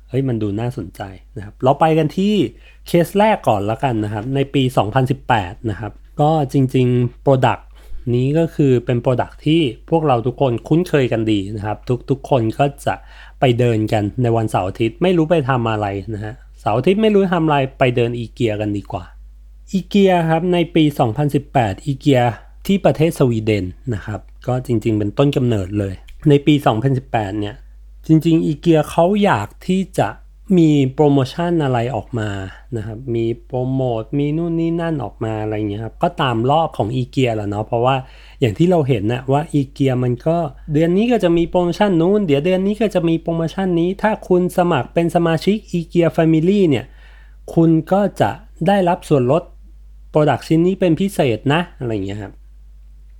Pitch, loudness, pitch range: 135 Hz, -17 LUFS, 110-165 Hz